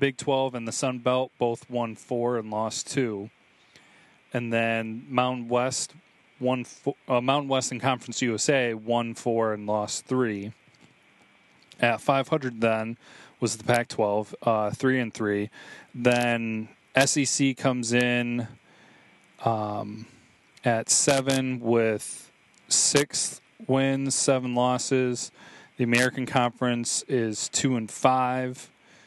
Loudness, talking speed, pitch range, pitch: -26 LUFS, 120 wpm, 115-130 Hz, 125 Hz